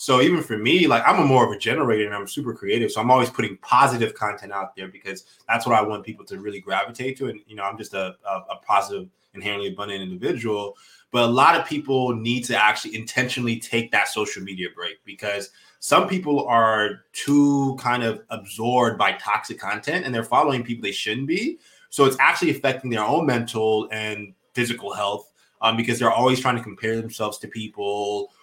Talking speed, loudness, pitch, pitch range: 205 wpm, -22 LUFS, 115 Hz, 105-125 Hz